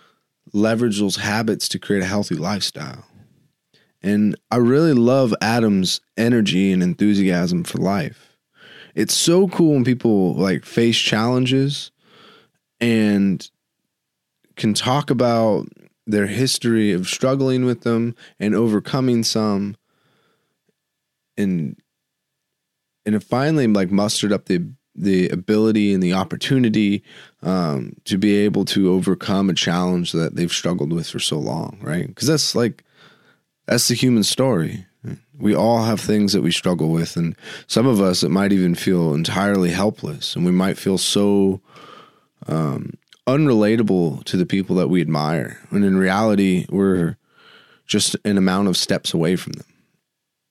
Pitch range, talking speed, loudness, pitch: 95-120 Hz, 140 wpm, -19 LUFS, 105 Hz